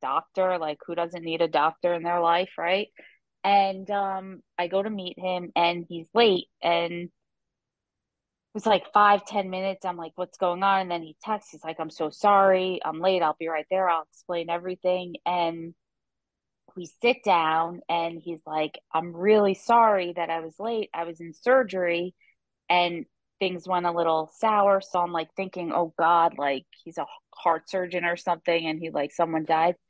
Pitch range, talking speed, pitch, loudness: 165-190 Hz, 185 wpm, 175 Hz, -25 LUFS